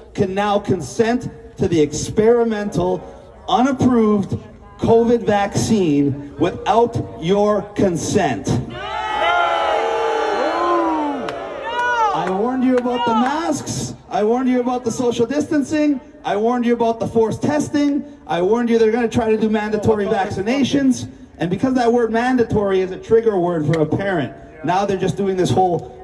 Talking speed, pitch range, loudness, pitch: 140 wpm, 195-250 Hz, -18 LUFS, 225 Hz